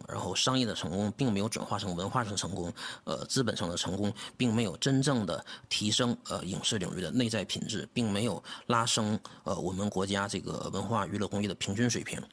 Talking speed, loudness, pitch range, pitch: 325 characters per minute, -32 LUFS, 100-120 Hz, 105 Hz